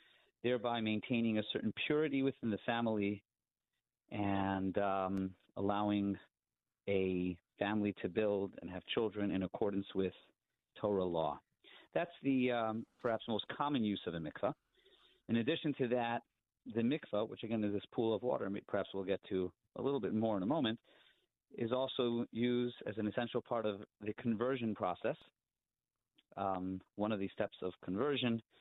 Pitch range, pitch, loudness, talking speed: 100-120 Hz, 110 Hz, -38 LUFS, 155 wpm